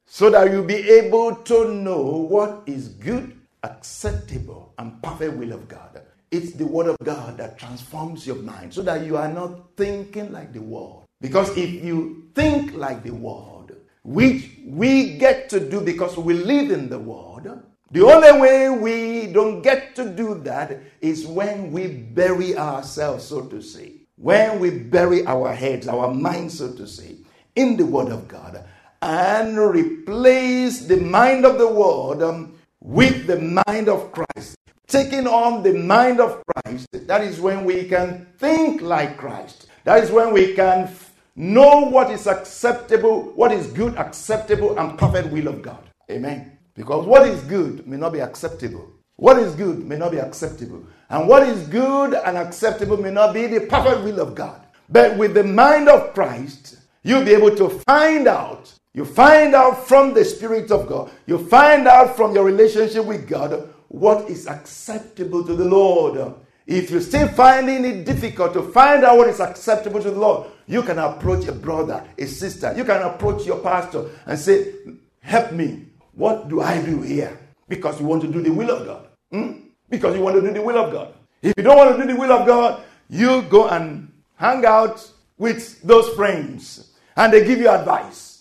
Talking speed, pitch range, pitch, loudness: 185 wpm, 165-245 Hz, 200 Hz, -17 LUFS